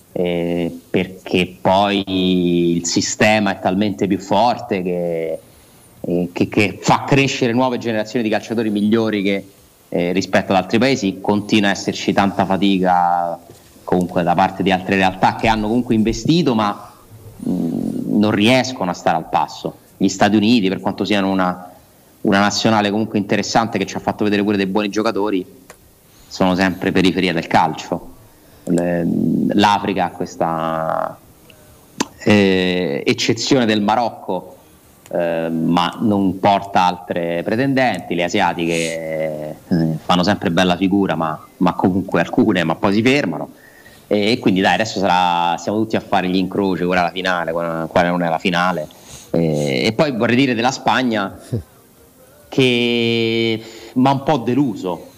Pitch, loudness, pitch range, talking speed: 95 Hz, -17 LUFS, 90-110 Hz, 145 wpm